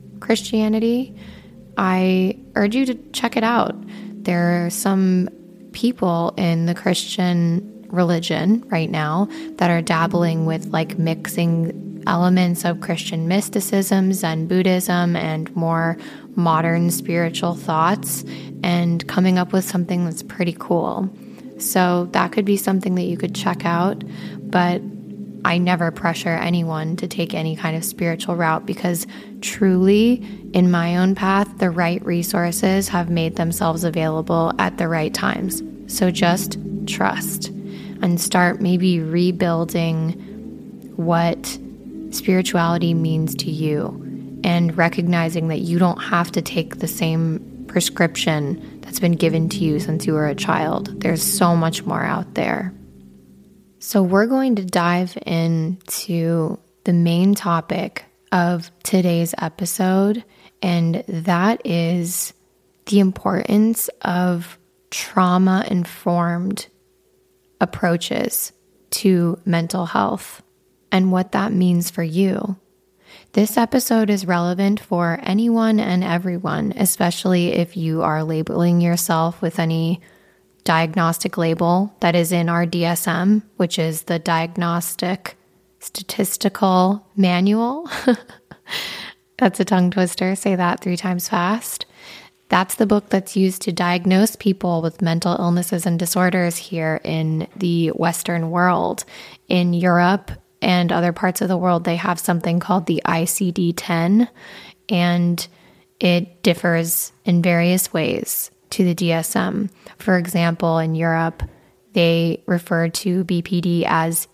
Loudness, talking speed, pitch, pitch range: -19 LUFS, 125 wpm, 180 Hz, 170-195 Hz